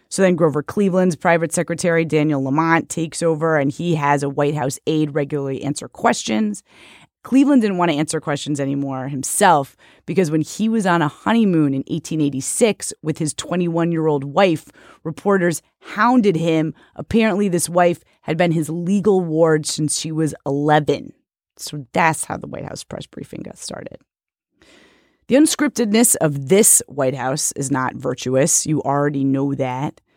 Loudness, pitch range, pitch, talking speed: -18 LUFS, 145-175 Hz, 155 Hz, 160 wpm